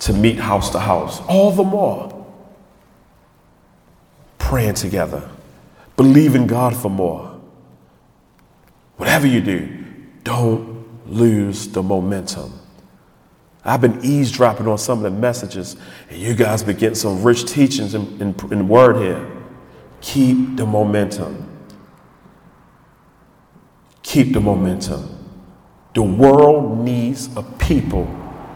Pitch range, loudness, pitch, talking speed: 100-130 Hz, -16 LUFS, 115 Hz, 115 wpm